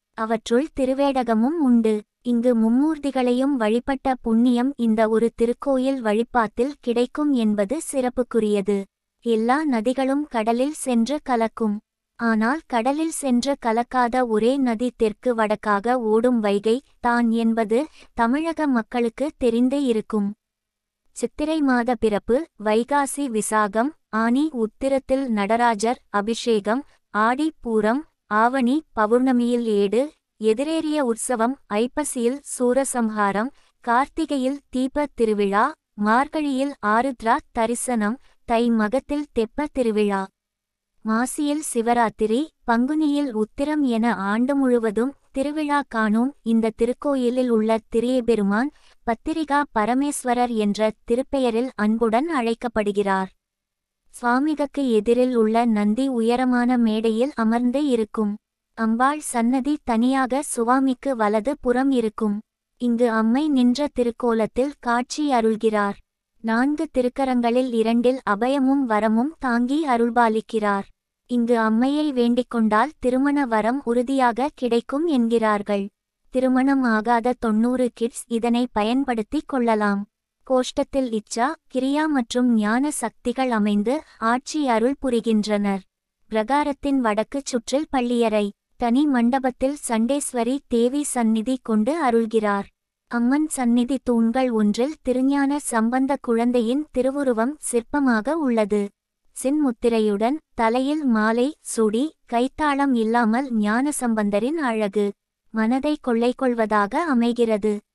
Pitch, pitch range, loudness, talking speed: 240 Hz, 225-270 Hz, -22 LUFS, 95 wpm